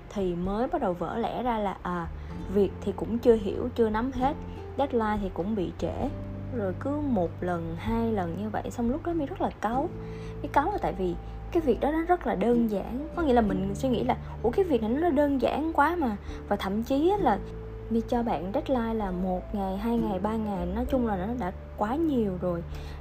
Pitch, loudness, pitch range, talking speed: 225 Hz, -28 LUFS, 185-255 Hz, 230 wpm